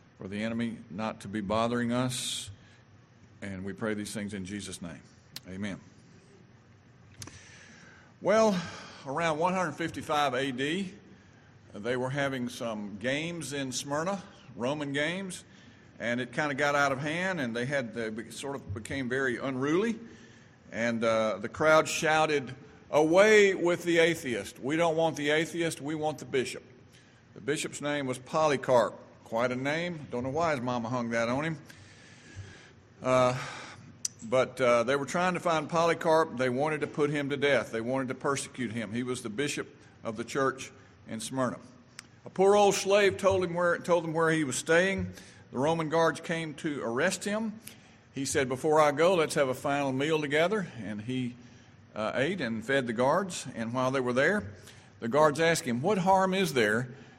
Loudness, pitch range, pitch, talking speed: -29 LUFS, 120-160 Hz, 130 Hz, 170 wpm